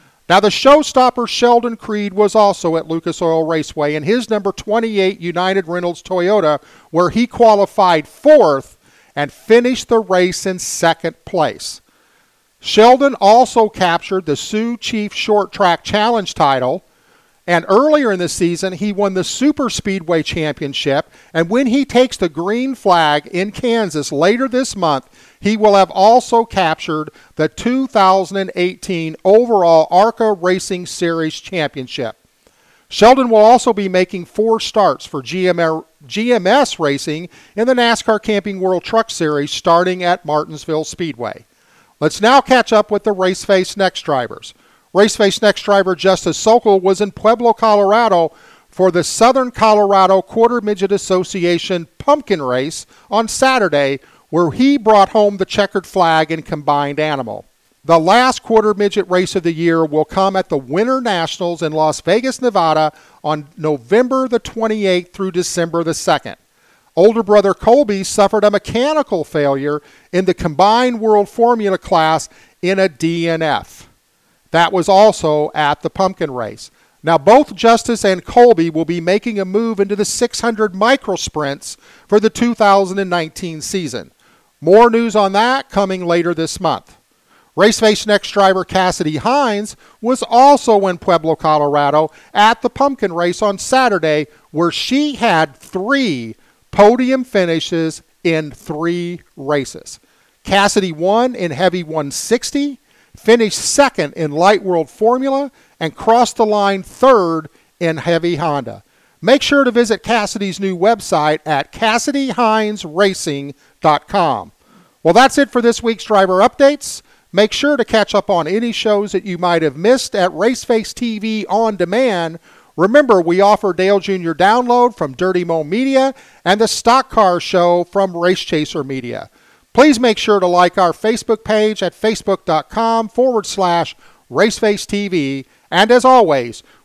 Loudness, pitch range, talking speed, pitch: -14 LUFS, 165-225 Hz, 145 wpm, 195 Hz